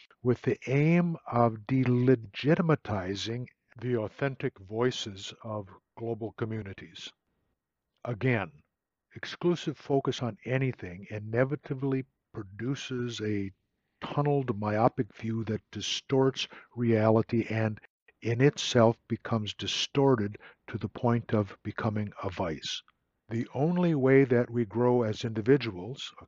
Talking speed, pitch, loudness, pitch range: 105 wpm, 120 Hz, -29 LUFS, 110-130 Hz